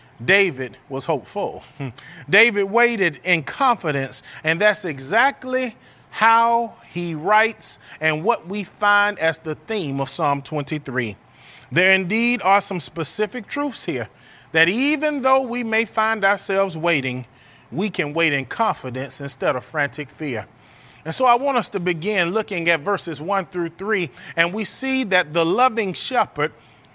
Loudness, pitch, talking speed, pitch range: -20 LUFS, 180 Hz, 150 wpm, 145-215 Hz